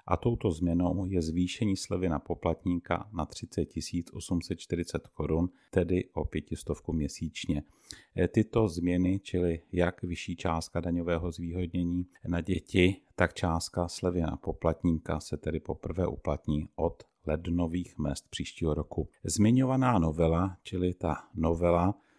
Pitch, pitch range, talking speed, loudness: 90 Hz, 80-90 Hz, 120 wpm, -31 LUFS